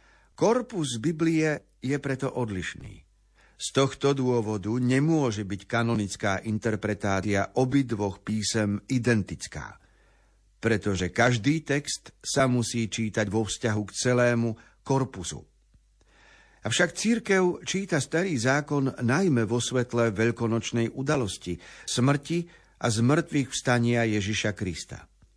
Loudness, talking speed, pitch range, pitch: -27 LUFS, 100 wpm, 110-140 Hz, 120 Hz